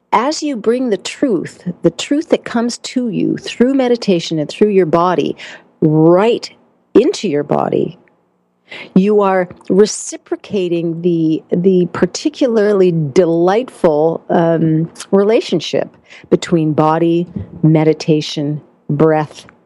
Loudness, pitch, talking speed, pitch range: -14 LUFS, 180 Hz, 105 wpm, 160-215 Hz